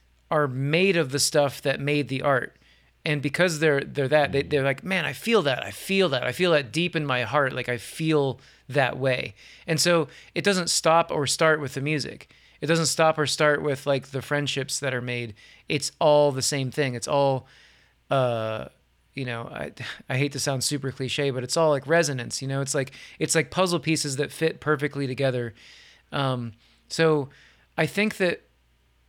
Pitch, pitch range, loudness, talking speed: 145 Hz, 130-155 Hz, -24 LUFS, 200 wpm